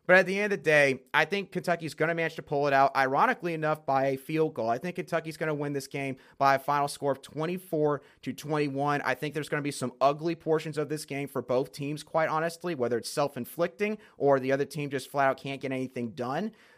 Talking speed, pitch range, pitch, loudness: 240 wpm, 135-165 Hz, 145 Hz, -29 LUFS